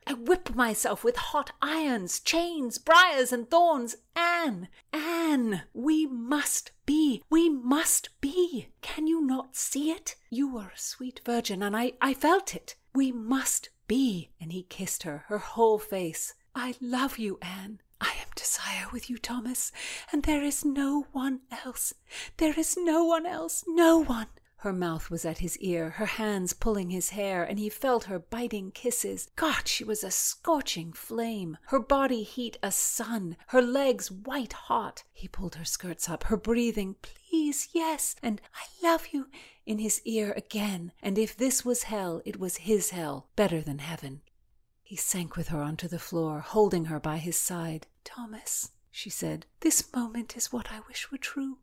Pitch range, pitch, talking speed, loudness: 190-285 Hz, 235 Hz, 175 wpm, -29 LUFS